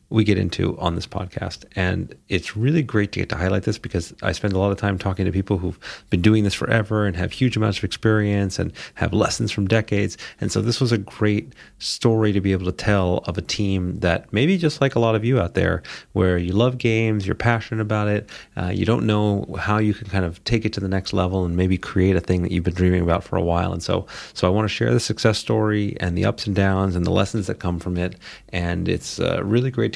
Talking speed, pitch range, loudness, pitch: 260 wpm, 90-110 Hz, -22 LUFS, 100 Hz